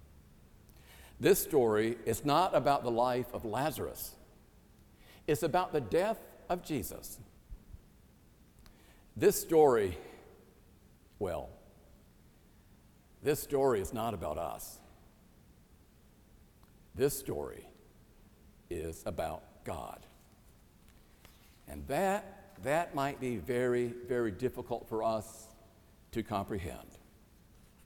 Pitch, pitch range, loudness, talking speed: 115 Hz, 100-140 Hz, -33 LUFS, 90 wpm